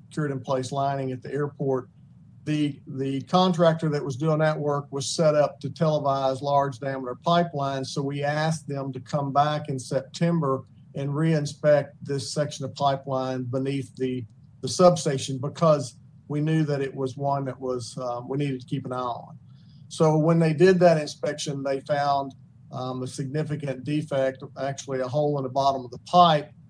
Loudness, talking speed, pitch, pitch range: -25 LUFS, 180 wpm, 140 Hz, 135-150 Hz